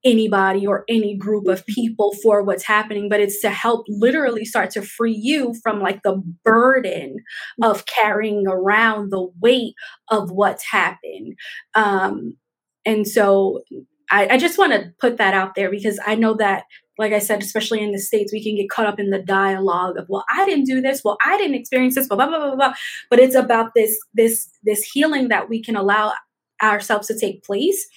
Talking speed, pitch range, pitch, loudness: 195 wpm, 200-240 Hz, 215 Hz, -18 LUFS